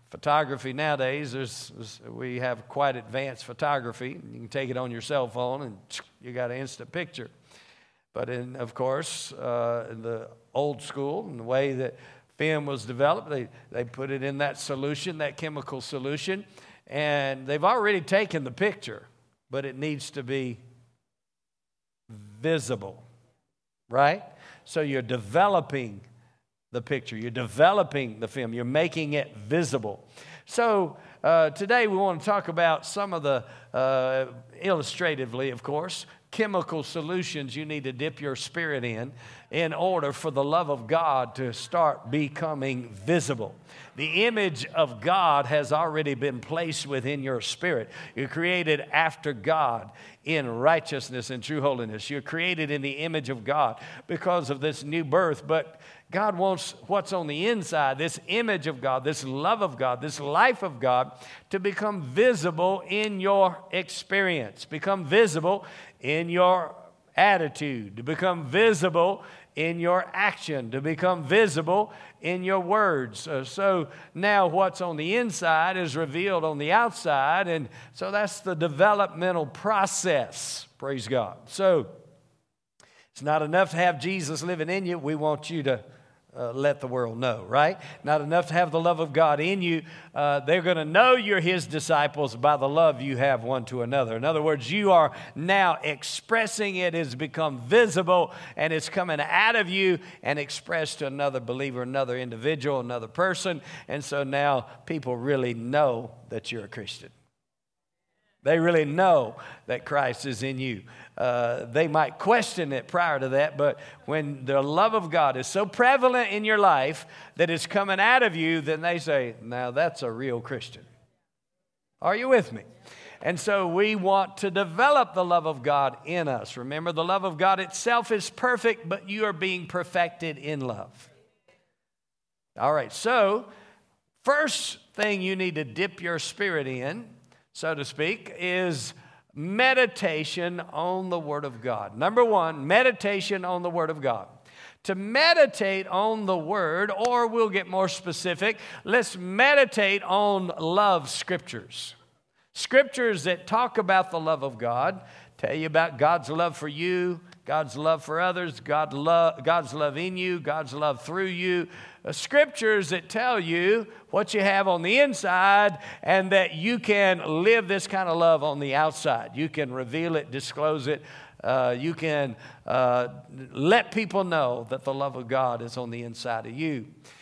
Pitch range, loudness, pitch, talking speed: 135-185 Hz, -26 LUFS, 155 Hz, 160 wpm